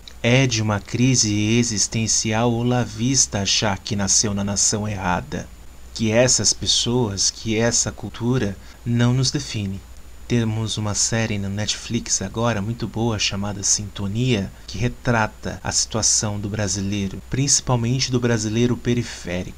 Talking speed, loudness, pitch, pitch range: 130 wpm, -20 LUFS, 110 Hz, 100-120 Hz